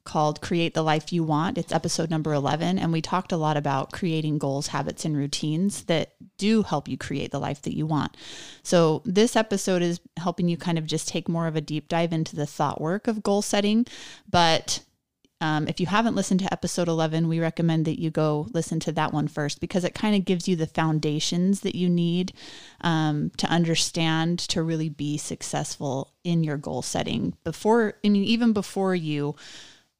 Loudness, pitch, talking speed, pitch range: -25 LUFS, 165 Hz, 200 wpm, 155-180 Hz